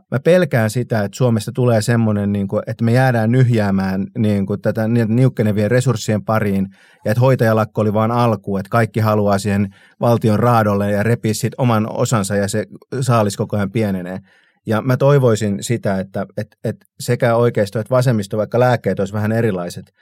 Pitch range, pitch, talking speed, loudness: 105-120 Hz, 110 Hz, 160 wpm, -17 LUFS